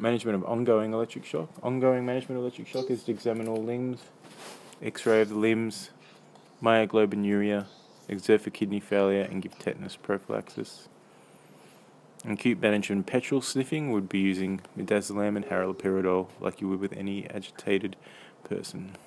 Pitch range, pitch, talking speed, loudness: 100-115 Hz, 105 Hz, 145 wpm, -29 LUFS